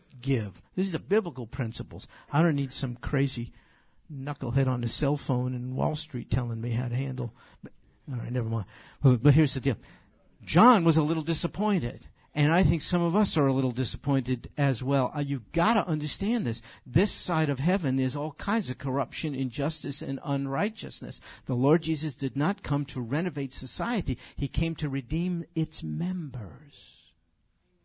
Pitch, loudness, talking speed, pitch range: 140 Hz, -28 LUFS, 185 wpm, 125-160 Hz